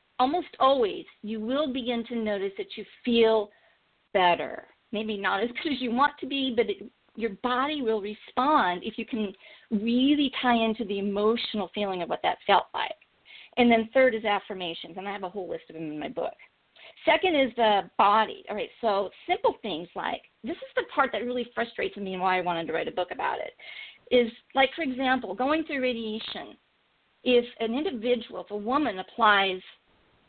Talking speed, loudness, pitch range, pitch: 195 wpm, -27 LUFS, 205-265 Hz, 235 Hz